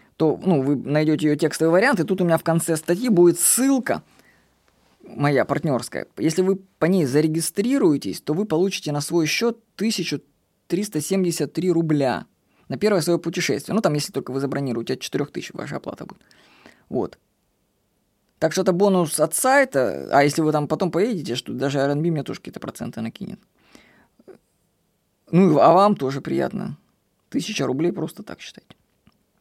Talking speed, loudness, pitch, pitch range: 155 wpm, -21 LUFS, 165 Hz, 145-190 Hz